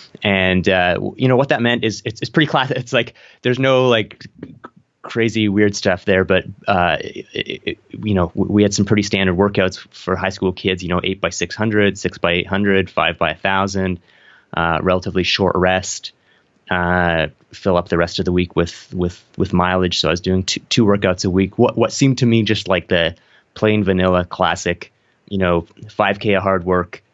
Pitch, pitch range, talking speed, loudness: 95 Hz, 90-105 Hz, 200 wpm, -17 LUFS